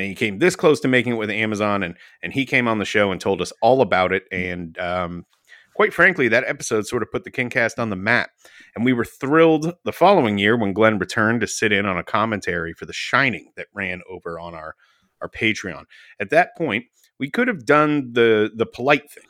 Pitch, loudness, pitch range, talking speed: 110 Hz, -19 LUFS, 95-130 Hz, 235 wpm